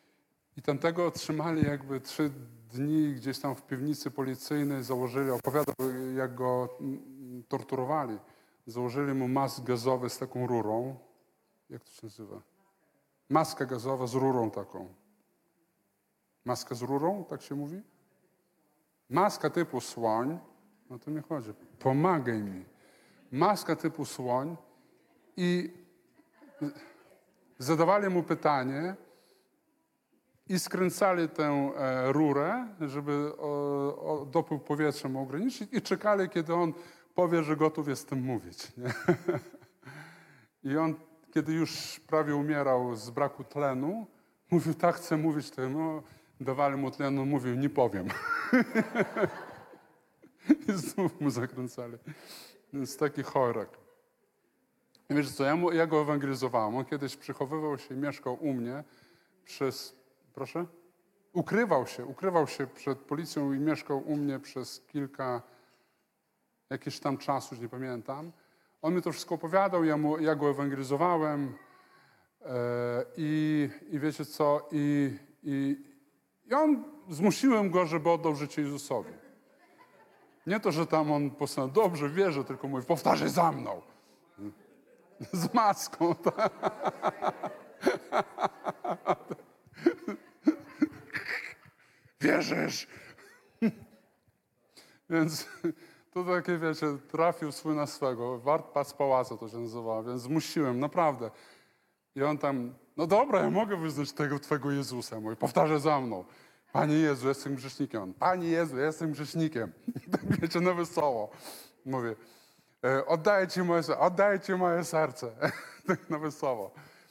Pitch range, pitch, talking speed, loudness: 135-170 Hz, 150 Hz, 120 wpm, -31 LUFS